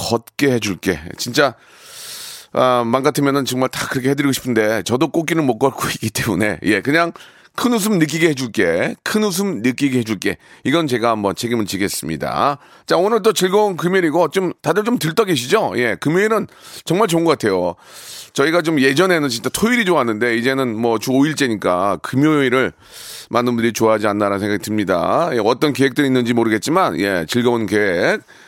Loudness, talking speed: -17 LUFS, 375 characters per minute